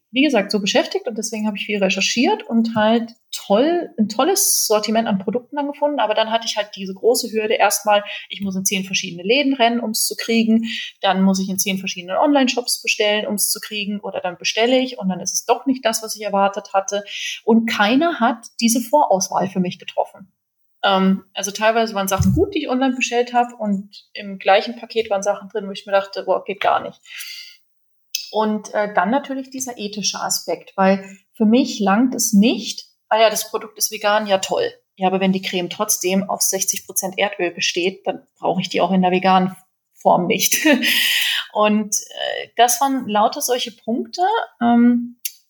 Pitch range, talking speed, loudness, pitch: 195-240 Hz, 200 wpm, -19 LUFS, 215 Hz